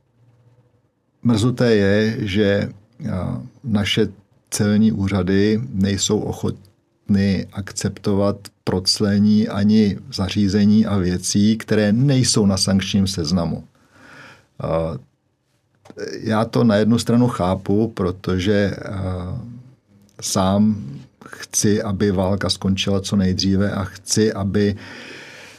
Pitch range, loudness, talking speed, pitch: 95-110 Hz, -19 LUFS, 85 wpm, 105 Hz